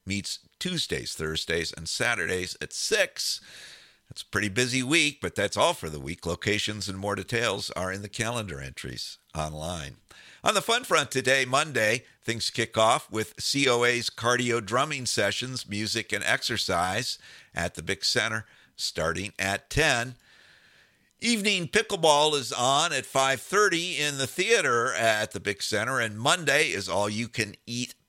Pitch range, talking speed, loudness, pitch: 95-135 Hz, 155 wpm, -26 LUFS, 115 Hz